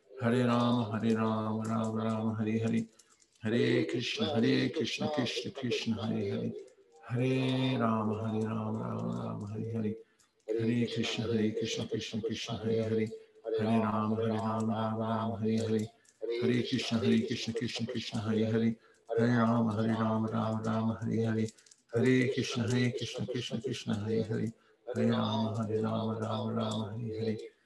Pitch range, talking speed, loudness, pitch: 110-115 Hz, 130 wpm, -32 LUFS, 110 Hz